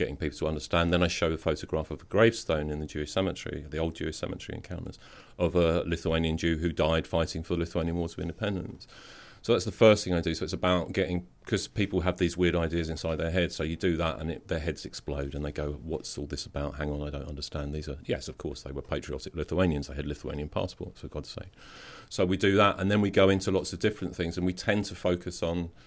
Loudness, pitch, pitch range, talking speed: -30 LUFS, 85 Hz, 75-90 Hz, 255 wpm